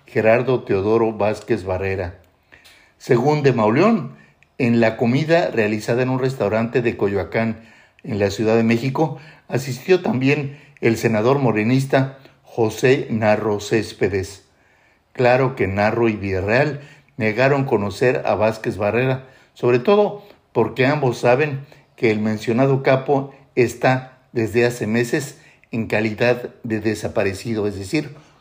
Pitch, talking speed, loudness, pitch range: 120 Hz, 125 wpm, -19 LUFS, 110-135 Hz